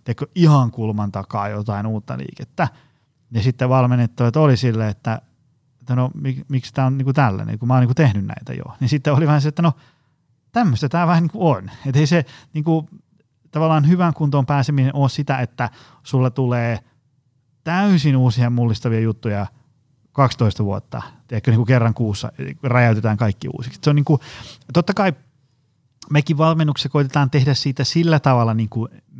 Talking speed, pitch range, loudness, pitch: 165 wpm, 120-150 Hz, -19 LUFS, 130 Hz